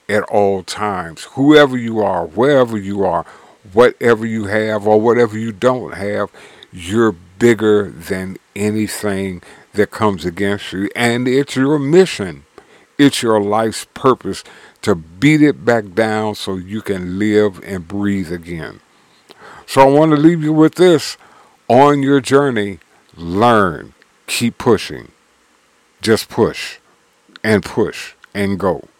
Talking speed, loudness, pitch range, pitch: 135 wpm, -15 LUFS, 100-125 Hz, 110 Hz